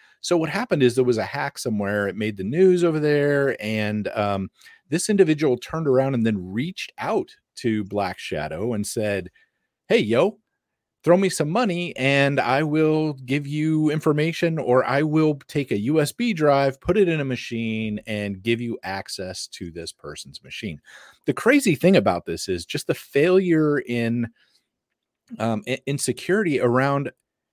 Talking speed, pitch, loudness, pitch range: 165 wpm, 135 Hz, -22 LUFS, 110-155 Hz